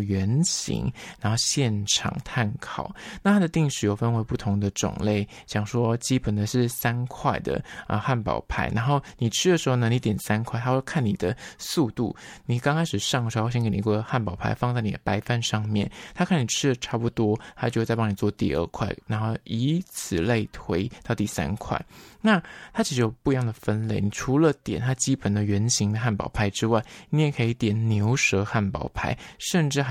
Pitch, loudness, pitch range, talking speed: 115 Hz, -25 LUFS, 105-130 Hz, 290 characters per minute